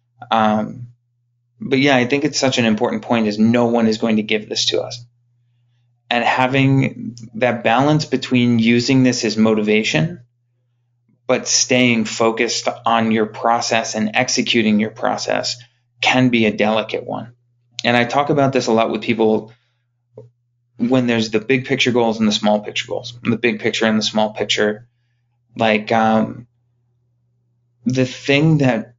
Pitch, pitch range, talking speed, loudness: 120 Hz, 110-125 Hz, 155 wpm, -17 LUFS